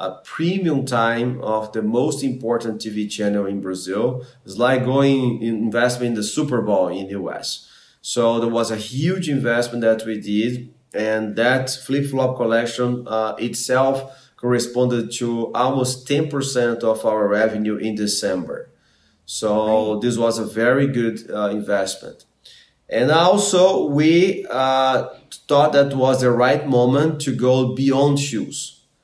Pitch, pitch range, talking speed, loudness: 120 Hz, 110-130 Hz, 145 wpm, -20 LUFS